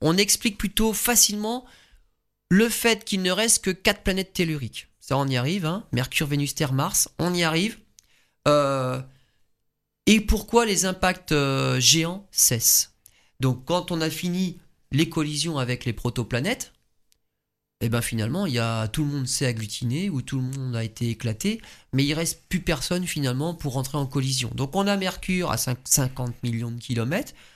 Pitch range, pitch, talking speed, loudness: 125-185 Hz, 145 Hz, 180 wpm, -23 LUFS